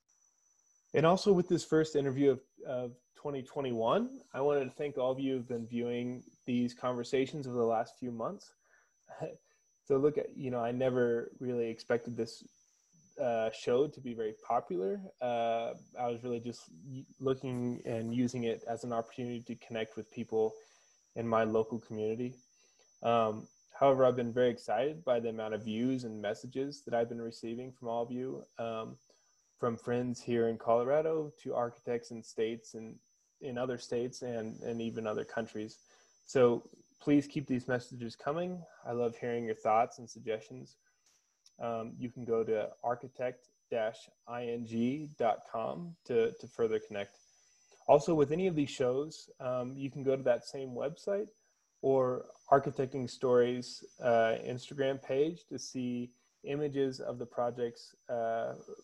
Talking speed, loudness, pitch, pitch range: 155 wpm, -34 LUFS, 125 Hz, 115-135 Hz